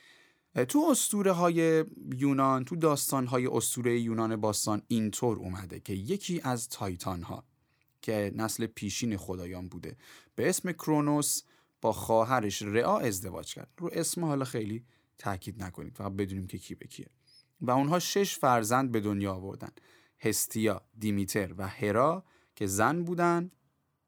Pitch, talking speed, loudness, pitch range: 115 Hz, 140 wpm, -30 LUFS, 105-155 Hz